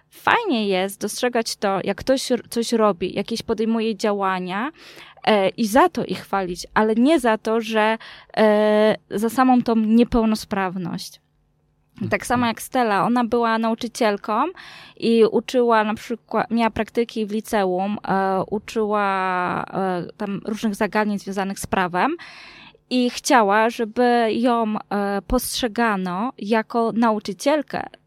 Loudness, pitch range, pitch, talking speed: -21 LUFS, 200-235 Hz, 220 Hz, 125 wpm